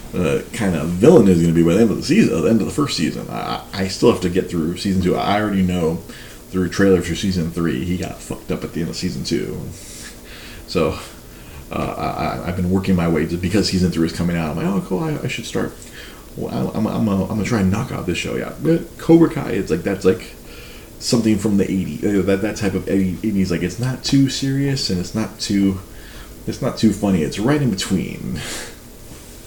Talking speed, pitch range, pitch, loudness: 240 wpm, 85-110 Hz, 95 Hz, -19 LUFS